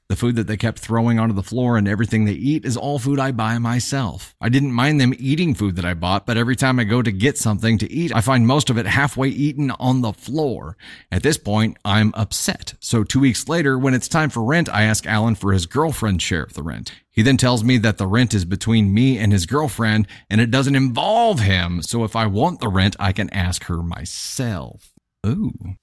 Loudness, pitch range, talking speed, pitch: -19 LUFS, 105-135 Hz, 235 wpm, 115 Hz